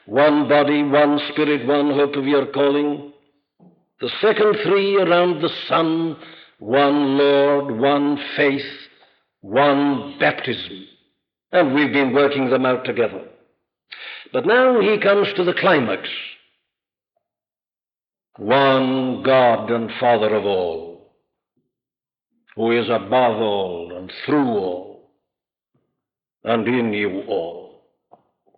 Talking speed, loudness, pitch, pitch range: 110 wpm, -18 LUFS, 145 Hz, 130-165 Hz